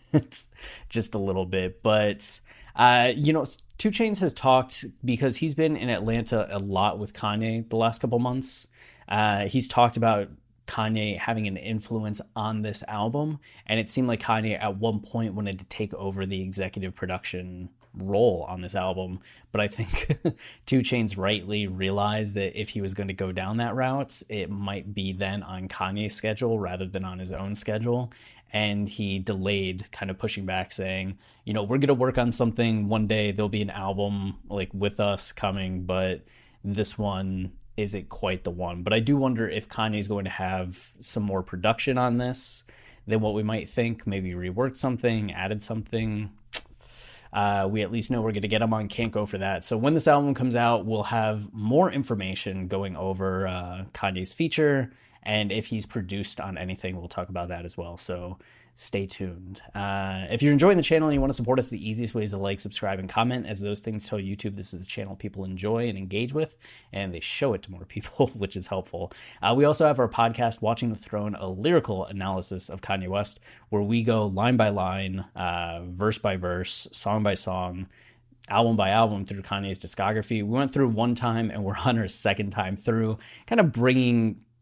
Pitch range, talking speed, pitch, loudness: 95-115 Hz, 200 wpm, 105 Hz, -27 LUFS